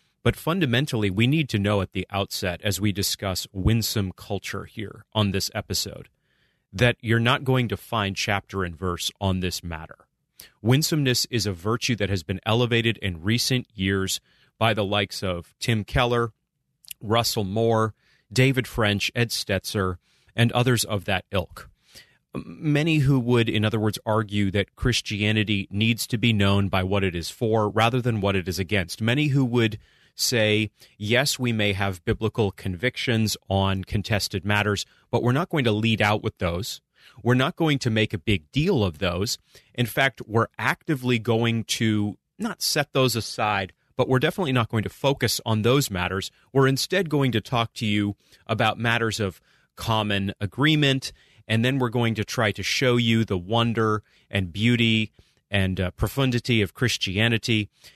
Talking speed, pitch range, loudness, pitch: 170 wpm, 100-120 Hz, -24 LUFS, 110 Hz